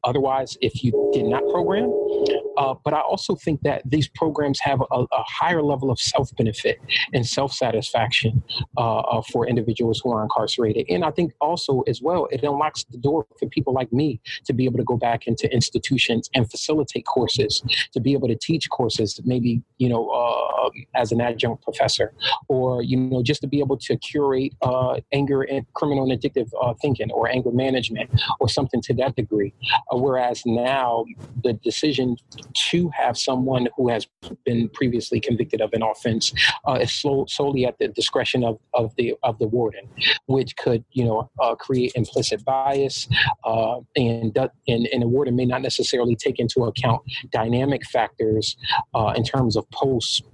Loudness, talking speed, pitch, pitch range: -22 LUFS, 175 wpm, 130 Hz, 120-140 Hz